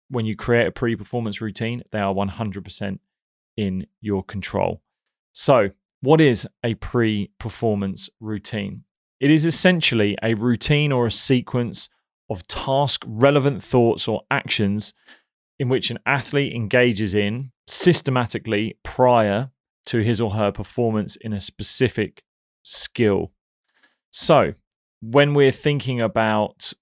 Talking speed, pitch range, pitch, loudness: 125 wpm, 105-130 Hz, 115 Hz, -21 LUFS